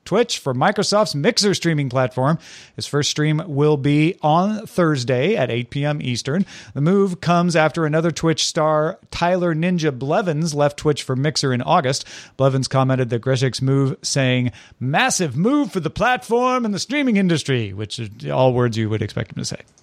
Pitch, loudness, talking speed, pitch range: 150 Hz, -19 LUFS, 175 wpm, 130-175 Hz